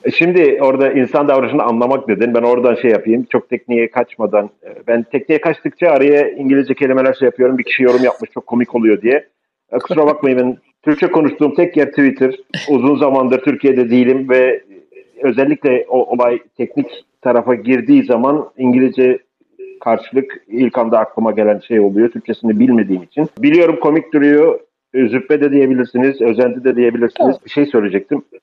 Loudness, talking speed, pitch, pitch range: -13 LUFS, 155 wpm, 130 Hz, 120-145 Hz